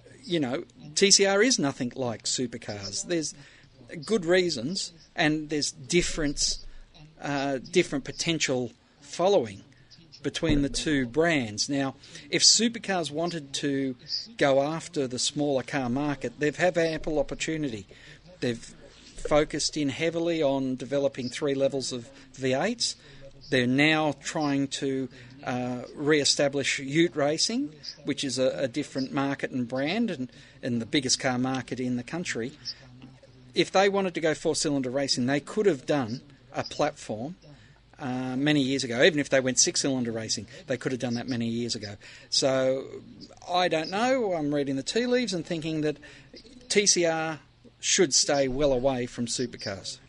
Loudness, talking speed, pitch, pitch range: -27 LUFS, 150 wpm, 140 Hz, 130-160 Hz